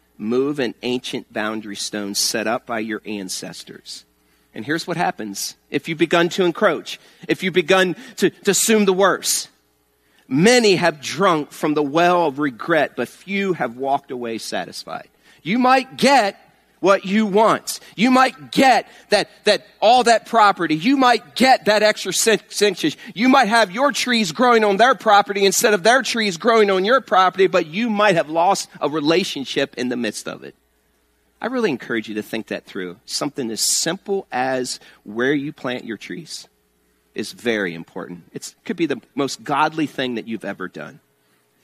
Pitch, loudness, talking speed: 170 Hz, -18 LUFS, 185 wpm